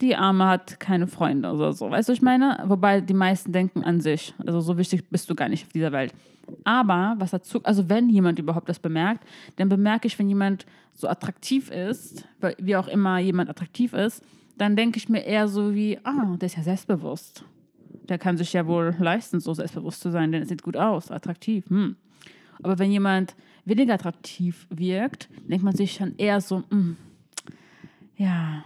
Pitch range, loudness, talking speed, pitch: 175-205 Hz, -24 LUFS, 200 wpm, 190 Hz